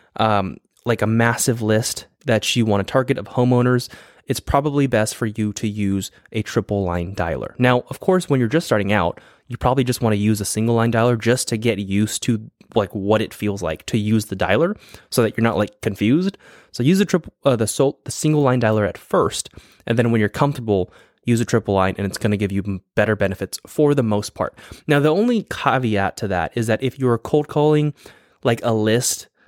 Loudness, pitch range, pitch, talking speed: -20 LUFS, 105-130 Hz, 115 Hz, 225 wpm